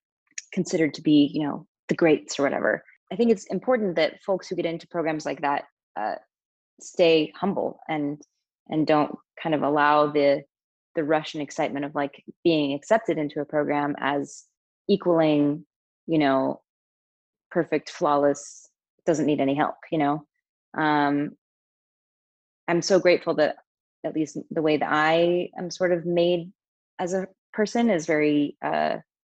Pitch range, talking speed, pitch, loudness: 145-175 Hz, 155 wpm, 155 Hz, -24 LUFS